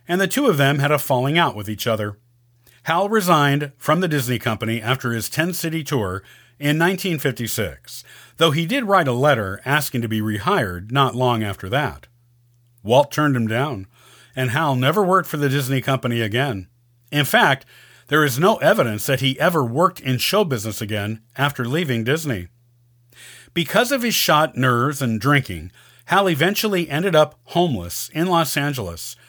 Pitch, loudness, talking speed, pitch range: 135 Hz, -19 LUFS, 170 wpm, 120-155 Hz